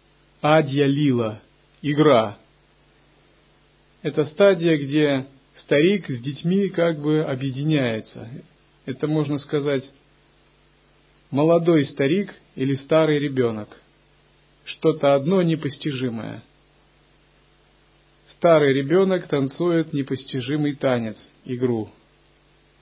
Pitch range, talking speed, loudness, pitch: 135-155 Hz, 75 wpm, -21 LUFS, 145 Hz